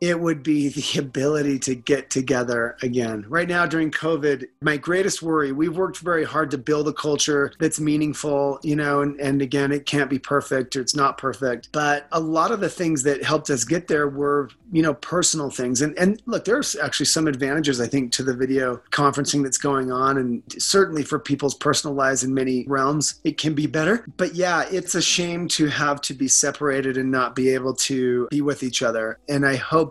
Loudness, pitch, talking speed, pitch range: -22 LUFS, 145 Hz, 215 wpm, 135-155 Hz